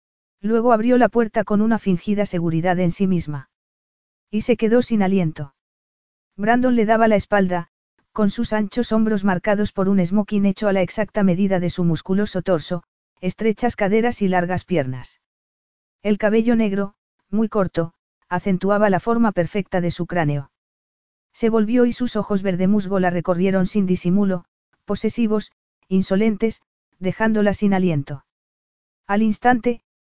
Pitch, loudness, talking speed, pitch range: 200 Hz, -20 LUFS, 145 wpm, 180-220 Hz